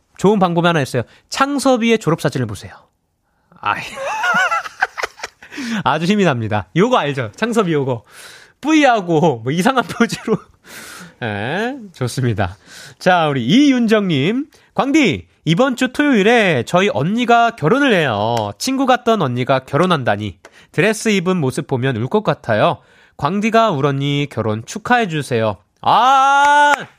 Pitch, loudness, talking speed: 185 Hz, -16 LUFS, 275 characters per minute